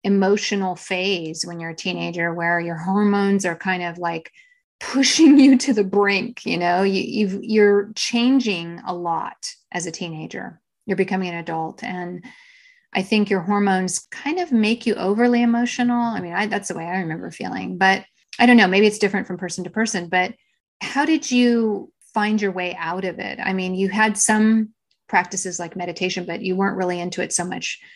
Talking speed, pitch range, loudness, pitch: 195 wpm, 180-225 Hz, -20 LUFS, 195 Hz